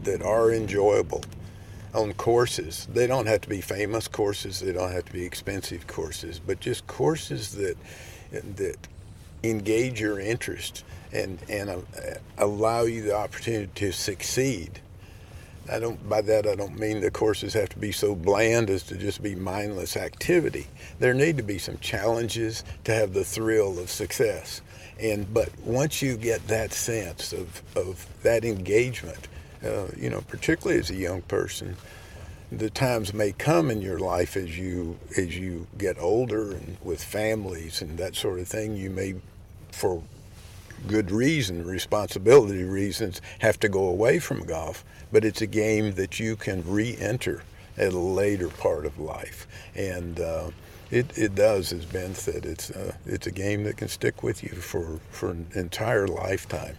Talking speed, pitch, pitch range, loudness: 165 wpm, 100 Hz, 90-110 Hz, -27 LUFS